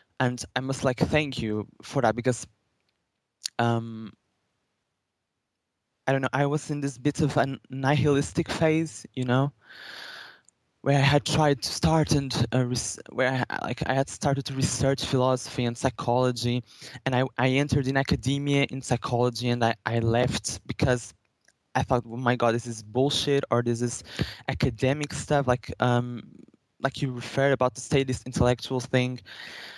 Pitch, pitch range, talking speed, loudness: 130 Hz, 120-140 Hz, 165 wpm, -26 LUFS